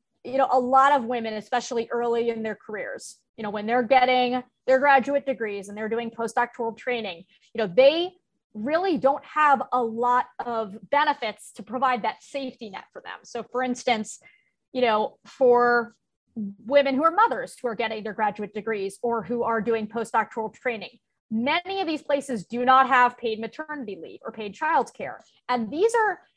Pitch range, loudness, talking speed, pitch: 225-275 Hz, -24 LUFS, 180 wpm, 245 Hz